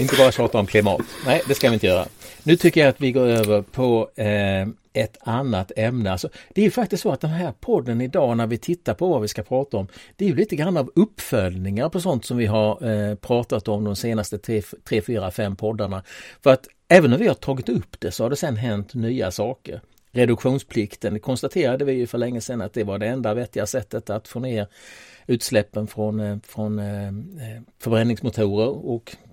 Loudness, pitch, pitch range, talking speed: -22 LUFS, 115 Hz, 105-130 Hz, 210 wpm